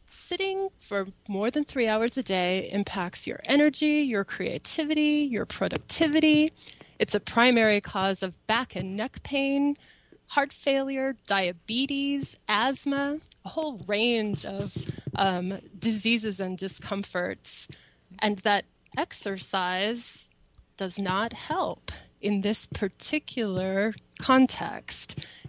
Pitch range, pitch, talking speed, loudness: 195-275 Hz, 220 Hz, 110 wpm, -27 LUFS